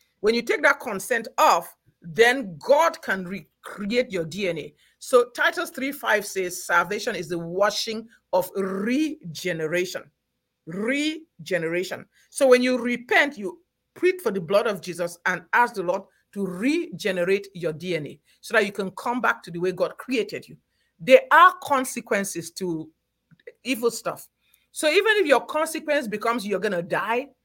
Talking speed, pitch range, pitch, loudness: 155 wpm, 180-265 Hz, 210 Hz, -23 LUFS